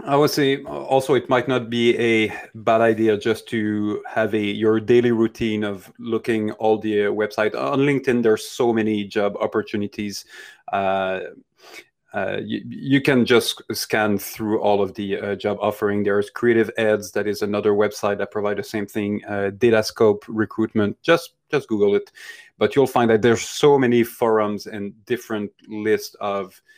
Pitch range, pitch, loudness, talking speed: 105-120 Hz, 110 Hz, -21 LUFS, 170 wpm